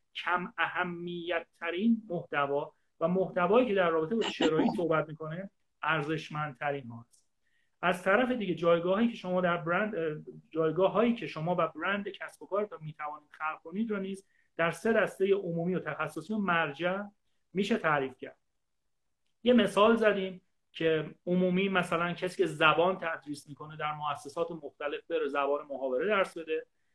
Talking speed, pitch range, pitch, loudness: 155 wpm, 155-195 Hz, 170 Hz, -31 LUFS